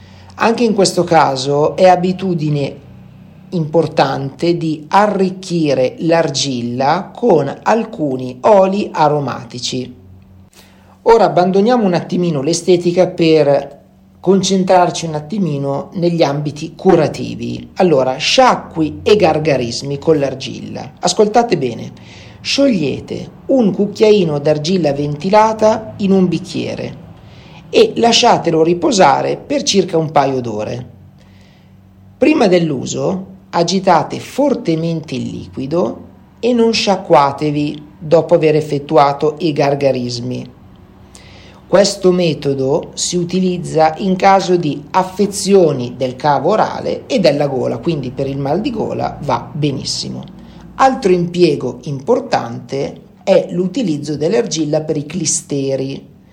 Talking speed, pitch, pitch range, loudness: 100 wpm, 160 Hz, 140-190 Hz, -14 LUFS